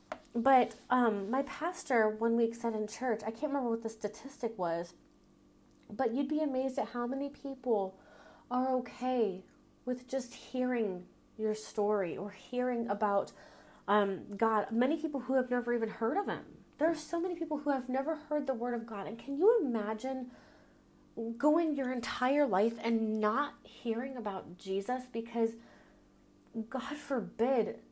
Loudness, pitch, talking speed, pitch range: -34 LUFS, 245 Hz, 160 wpm, 220-270 Hz